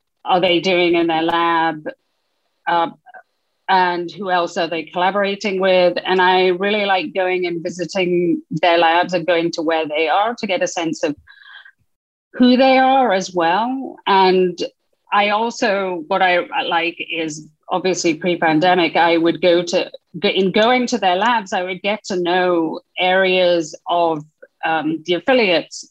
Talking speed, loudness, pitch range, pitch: 155 wpm, -17 LUFS, 170-195 Hz, 180 Hz